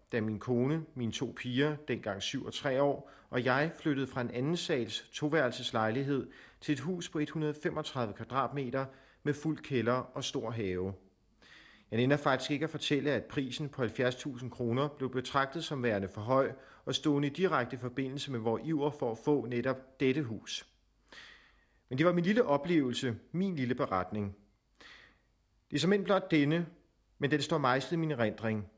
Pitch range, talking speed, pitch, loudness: 120-150 Hz, 175 wpm, 135 Hz, -33 LUFS